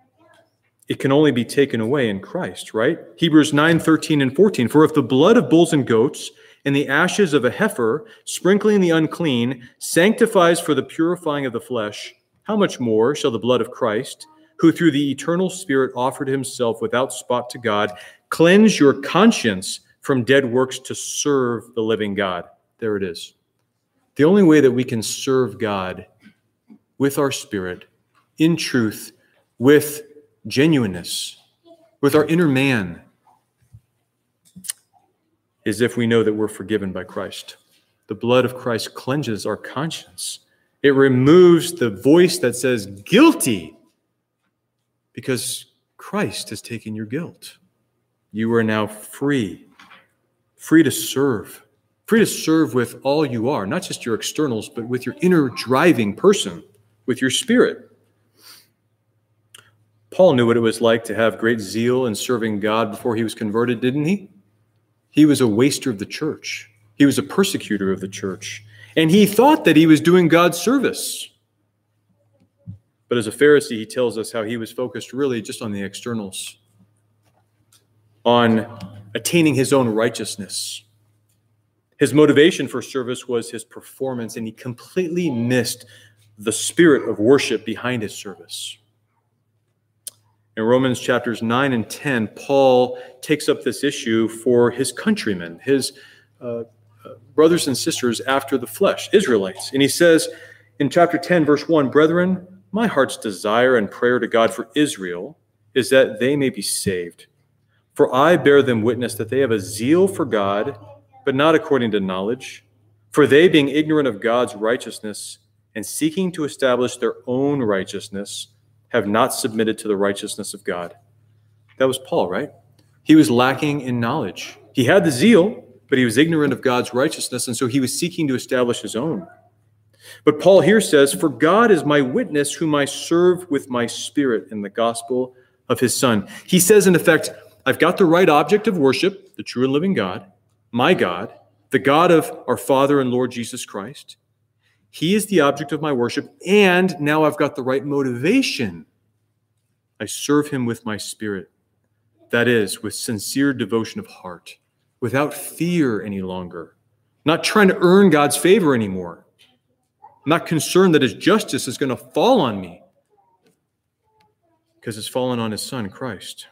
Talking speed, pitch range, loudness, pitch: 160 wpm, 110-145 Hz, -18 LUFS, 125 Hz